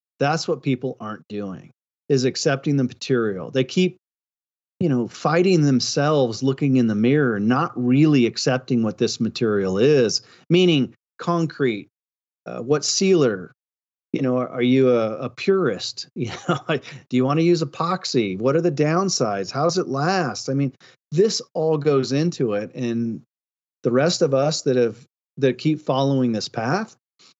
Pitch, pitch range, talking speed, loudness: 135 Hz, 120-160 Hz, 160 wpm, -21 LUFS